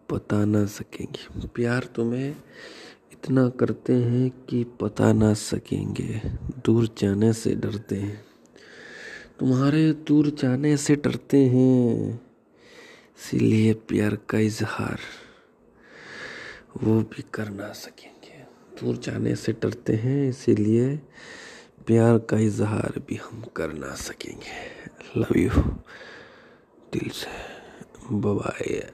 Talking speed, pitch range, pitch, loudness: 105 wpm, 105-130 Hz, 115 Hz, -24 LUFS